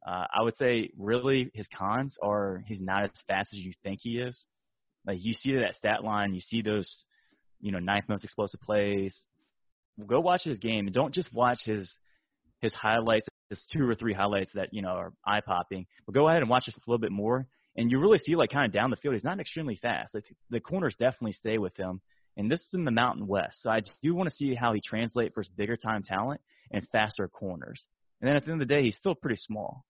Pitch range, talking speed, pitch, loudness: 100-125 Hz, 245 wpm, 110 Hz, -30 LUFS